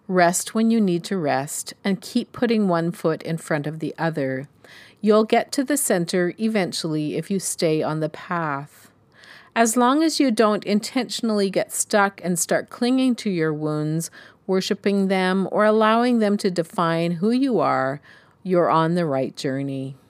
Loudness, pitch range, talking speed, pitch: -22 LUFS, 160-215 Hz, 170 wpm, 185 Hz